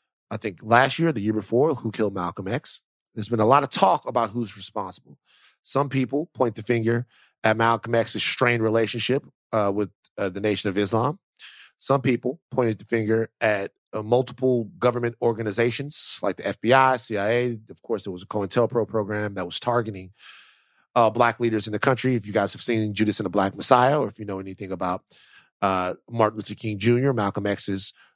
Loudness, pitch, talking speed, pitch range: -23 LUFS, 115 Hz, 190 wpm, 105-120 Hz